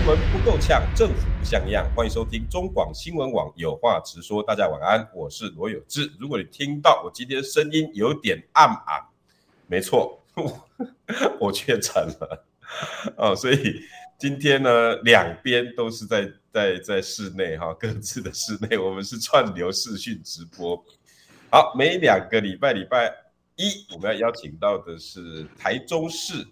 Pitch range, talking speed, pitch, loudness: 95-155 Hz, 230 characters per minute, 120 Hz, -23 LUFS